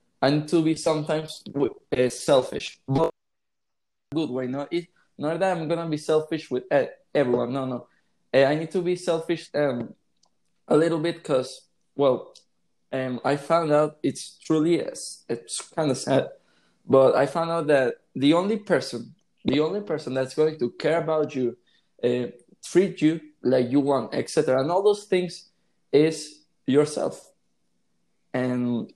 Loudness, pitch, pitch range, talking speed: -25 LUFS, 150 Hz, 130-165 Hz, 145 wpm